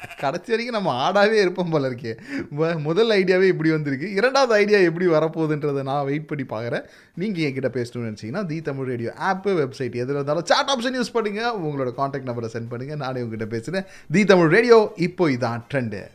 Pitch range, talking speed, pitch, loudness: 130-190 Hz, 180 wpm, 155 Hz, -22 LUFS